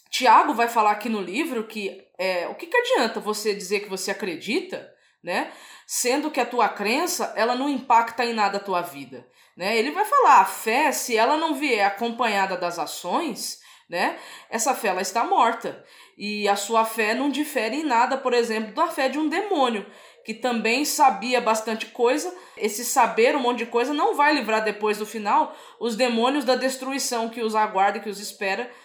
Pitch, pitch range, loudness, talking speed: 230 Hz, 210-270 Hz, -23 LUFS, 190 wpm